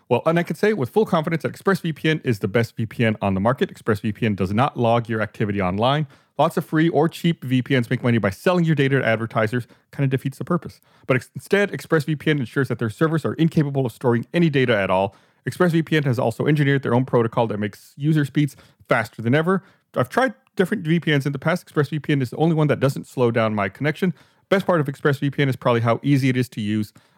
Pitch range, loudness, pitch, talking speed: 120-160 Hz, -21 LUFS, 140 Hz, 225 wpm